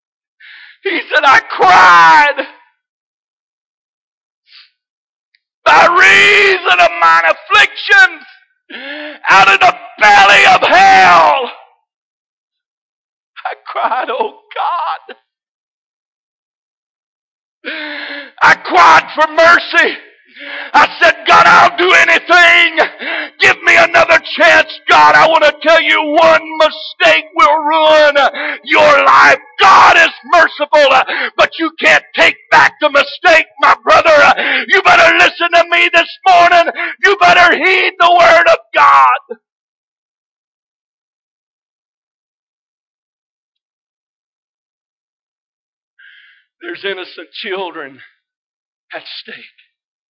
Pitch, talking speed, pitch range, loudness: 335 Hz, 90 wpm, 305-375 Hz, -8 LUFS